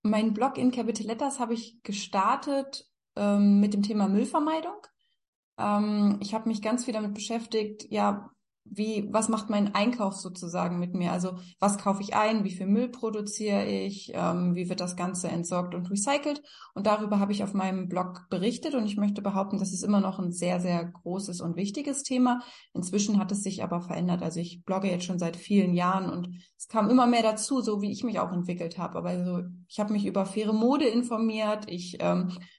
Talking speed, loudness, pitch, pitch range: 200 wpm, -28 LUFS, 205 Hz, 180-220 Hz